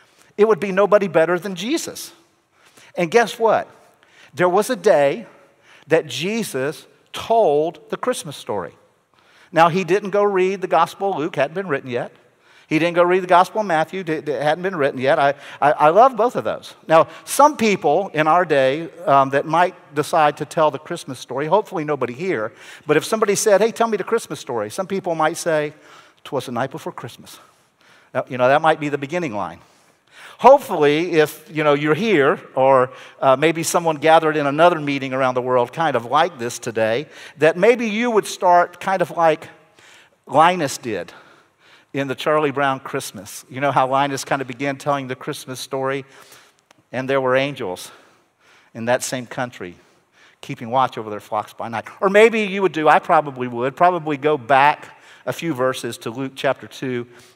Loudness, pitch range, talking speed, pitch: -19 LUFS, 135-185 Hz, 190 wpm, 155 Hz